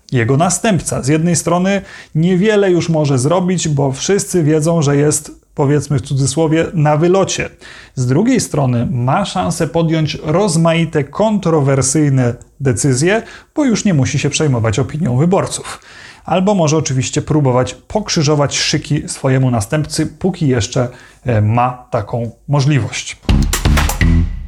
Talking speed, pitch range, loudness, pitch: 120 wpm, 130-165 Hz, -14 LUFS, 150 Hz